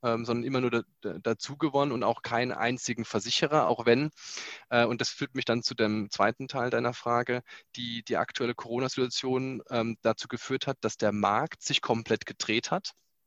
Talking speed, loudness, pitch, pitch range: 165 wpm, -29 LUFS, 120 Hz, 115-130 Hz